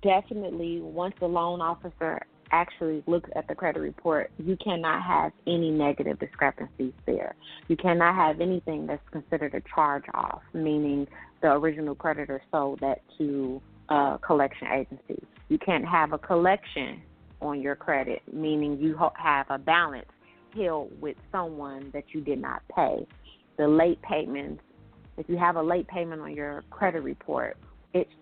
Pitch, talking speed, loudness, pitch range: 160 Hz, 155 wpm, -28 LUFS, 145-170 Hz